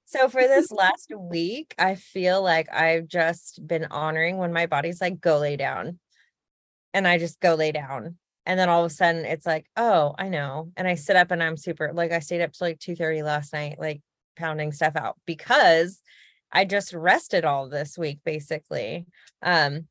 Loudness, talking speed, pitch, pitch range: -24 LUFS, 200 wpm, 165 Hz, 155-180 Hz